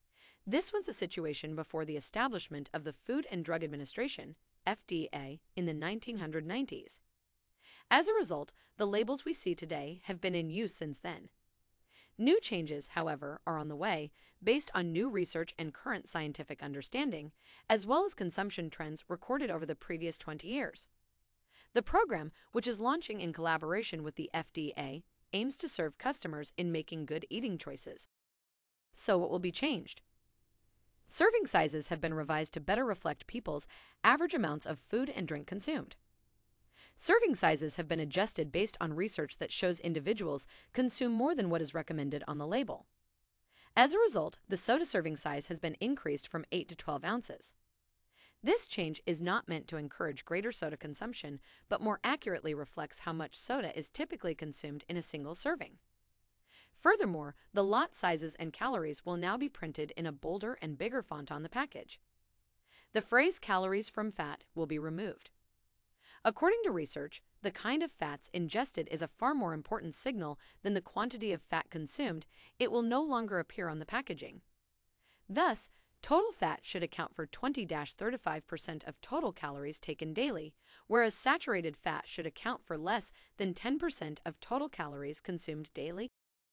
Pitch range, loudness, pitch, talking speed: 155-235 Hz, -36 LUFS, 175 Hz, 165 wpm